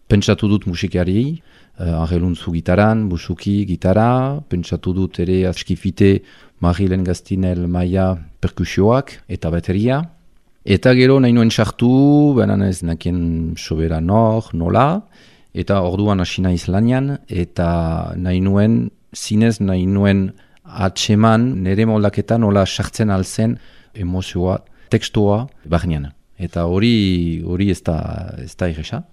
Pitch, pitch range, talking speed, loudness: 95 Hz, 90-110 Hz, 110 wpm, -17 LUFS